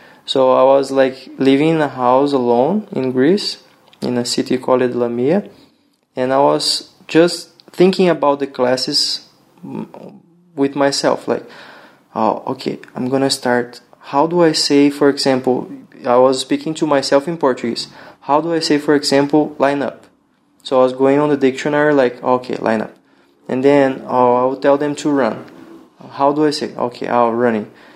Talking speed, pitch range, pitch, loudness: 175 wpm, 130-150 Hz, 140 Hz, -16 LUFS